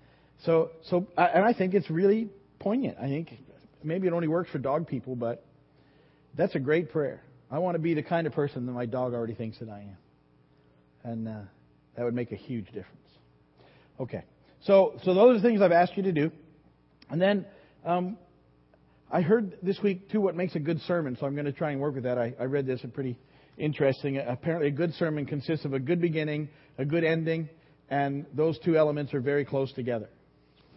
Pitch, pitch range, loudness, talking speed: 150 Hz, 125-175 Hz, -28 LUFS, 210 wpm